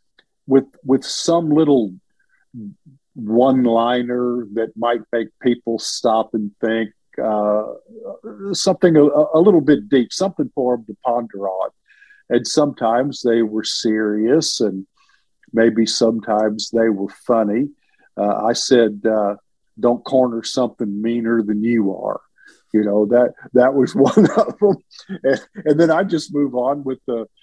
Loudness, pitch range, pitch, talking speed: -18 LUFS, 110-145 Hz, 120 Hz, 140 wpm